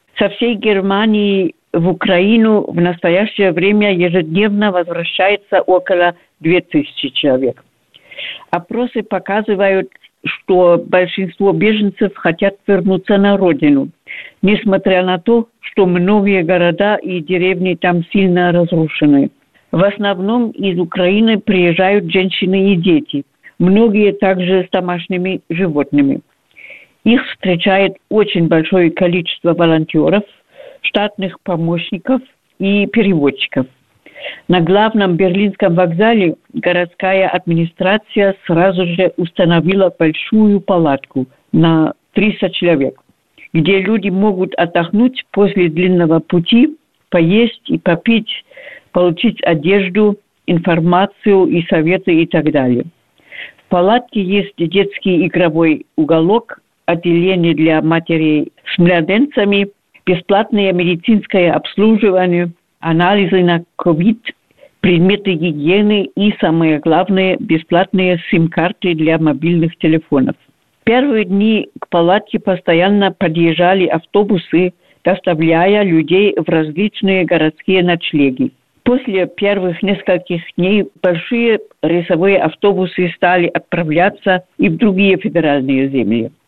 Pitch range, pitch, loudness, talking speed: 170-200 Hz, 185 Hz, -13 LUFS, 100 wpm